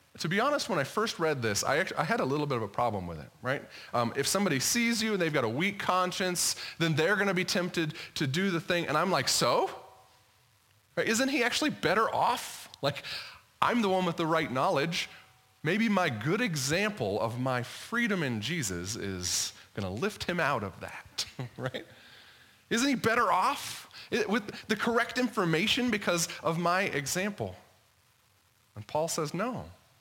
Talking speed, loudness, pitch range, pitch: 185 wpm, -30 LUFS, 120-195 Hz, 160 Hz